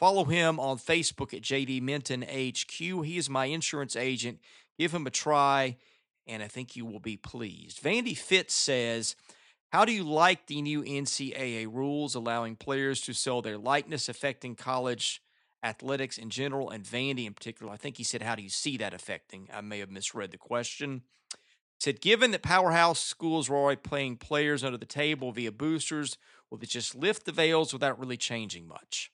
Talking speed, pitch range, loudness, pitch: 185 wpm, 120-150 Hz, -30 LUFS, 135 Hz